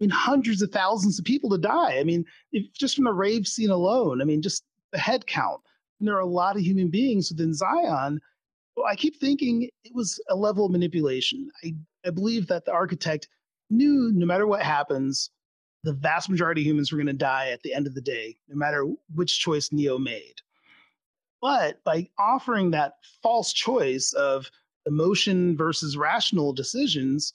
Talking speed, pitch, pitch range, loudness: 190 wpm, 180 Hz, 150-225 Hz, -25 LUFS